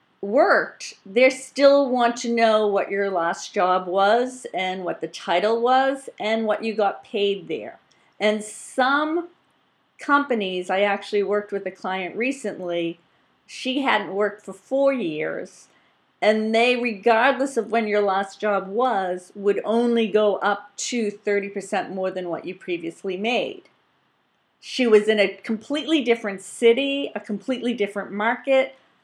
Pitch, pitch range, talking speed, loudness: 210 Hz, 195-240 Hz, 145 wpm, -22 LUFS